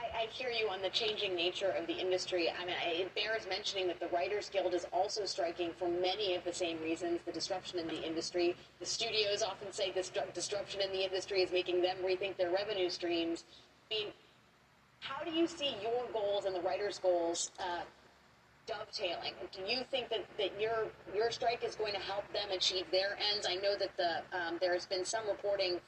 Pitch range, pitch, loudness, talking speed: 180-210 Hz, 190 Hz, -36 LUFS, 205 wpm